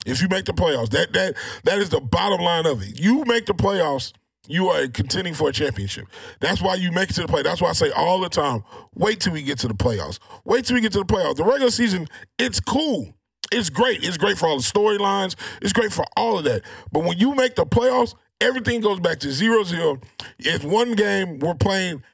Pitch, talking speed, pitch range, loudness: 190 Hz, 240 wpm, 150-220 Hz, -21 LUFS